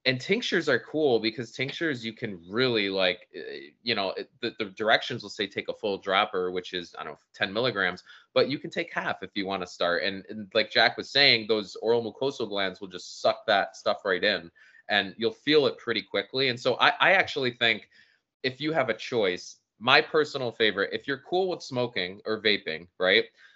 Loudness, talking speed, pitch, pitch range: -26 LUFS, 215 wpm, 125 Hz, 105-155 Hz